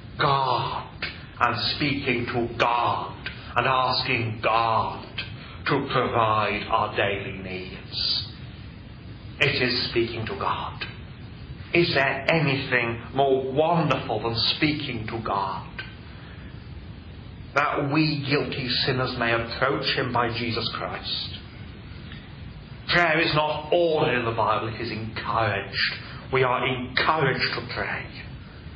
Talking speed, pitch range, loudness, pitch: 110 wpm, 110-135 Hz, -24 LUFS, 120 Hz